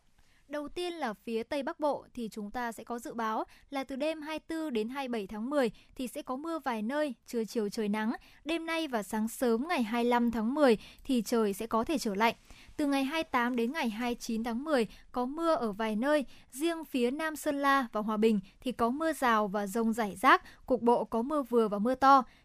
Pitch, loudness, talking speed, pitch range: 245 Hz, -31 LUFS, 225 wpm, 225-295 Hz